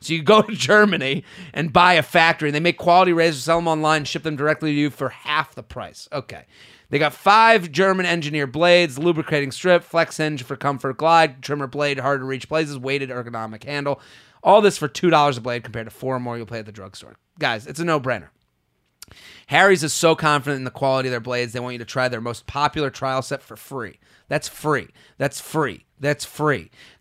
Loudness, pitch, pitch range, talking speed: -19 LUFS, 145 Hz, 130-165 Hz, 220 wpm